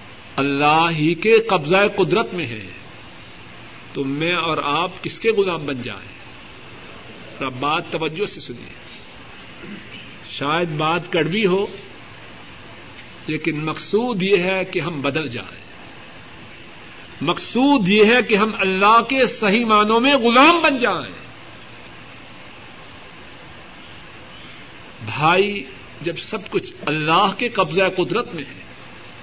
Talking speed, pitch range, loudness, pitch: 115 wpm, 150-210 Hz, -18 LUFS, 180 Hz